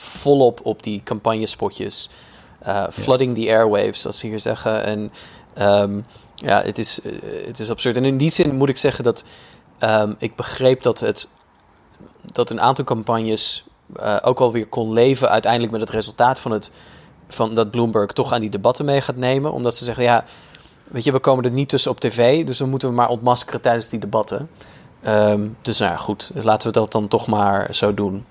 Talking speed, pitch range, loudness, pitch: 195 wpm, 110-125 Hz, -19 LUFS, 115 Hz